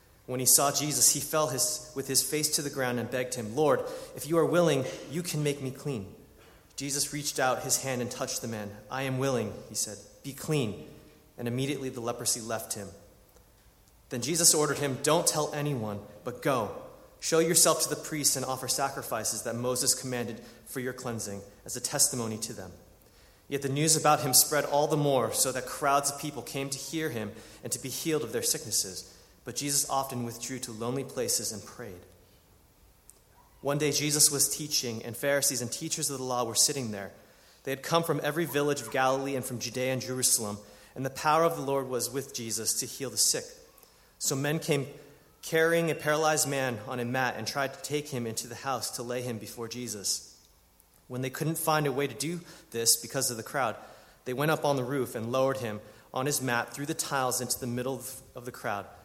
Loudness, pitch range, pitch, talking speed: -29 LUFS, 120-145 Hz, 130 Hz, 210 wpm